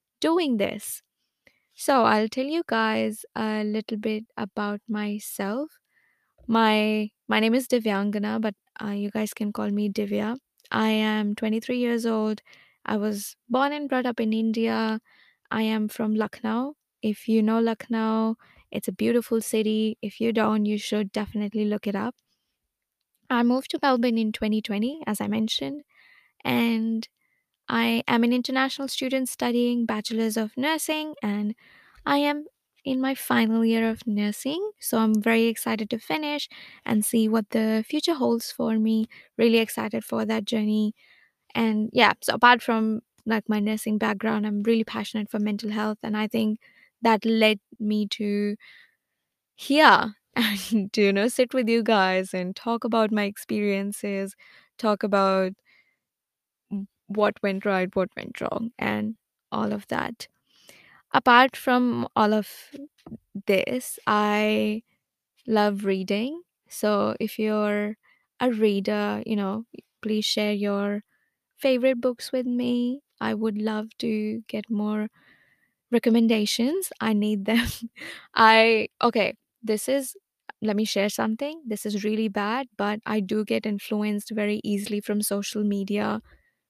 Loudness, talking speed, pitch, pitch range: -25 LUFS, 145 wpm, 220 Hz, 210-235 Hz